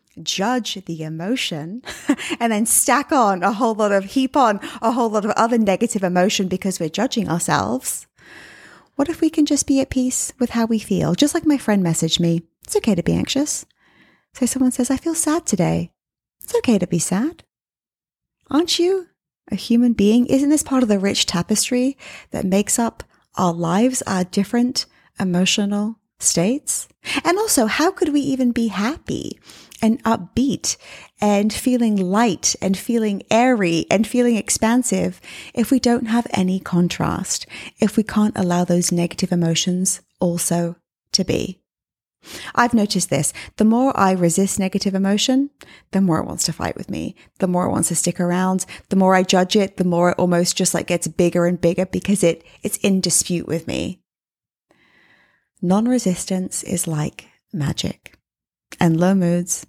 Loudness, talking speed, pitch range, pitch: -19 LUFS, 170 wpm, 180-245 Hz, 205 Hz